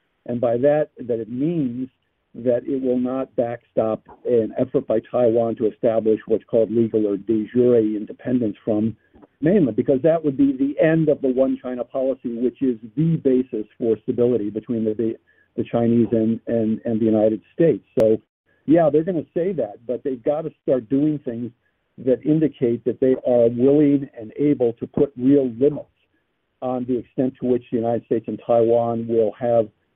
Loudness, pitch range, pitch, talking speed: -21 LUFS, 115-135 Hz, 120 Hz, 185 wpm